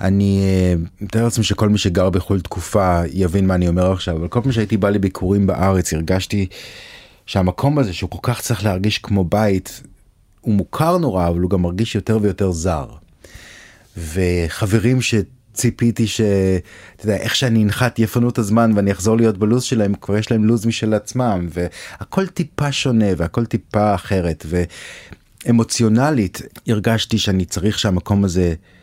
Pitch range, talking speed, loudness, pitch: 95-115 Hz, 150 wpm, -18 LUFS, 105 Hz